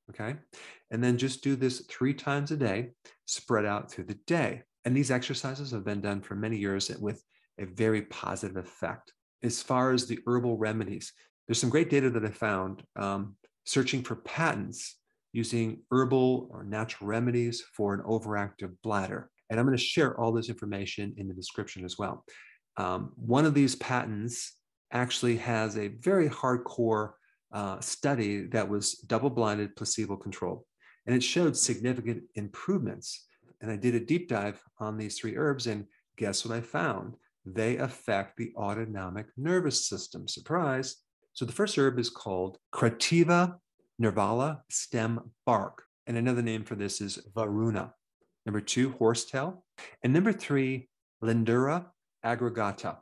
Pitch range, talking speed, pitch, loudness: 105-130 Hz, 155 wpm, 115 Hz, -31 LUFS